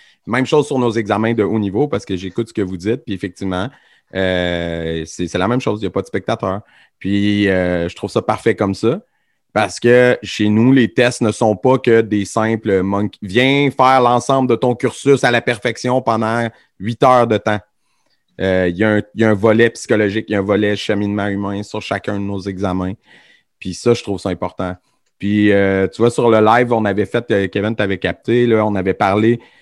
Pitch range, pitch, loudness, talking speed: 95-115 Hz, 105 Hz, -16 LUFS, 215 wpm